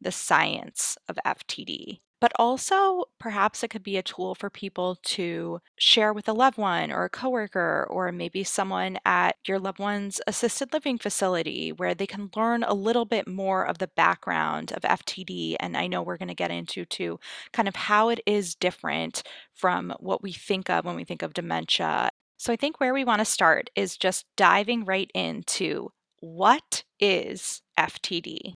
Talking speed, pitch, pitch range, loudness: 185 wpm, 200 Hz, 180-235 Hz, -26 LUFS